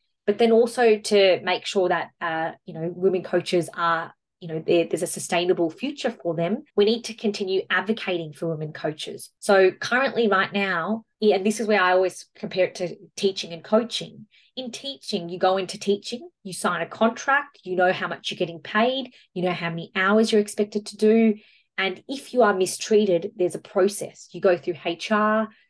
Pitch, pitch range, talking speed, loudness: 195 Hz, 180-220 Hz, 195 wpm, -23 LUFS